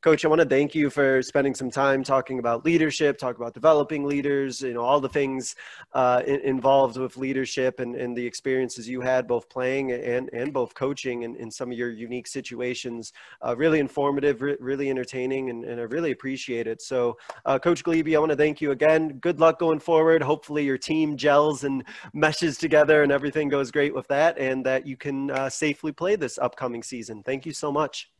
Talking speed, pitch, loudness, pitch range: 210 wpm, 135 Hz, -24 LUFS, 130-150 Hz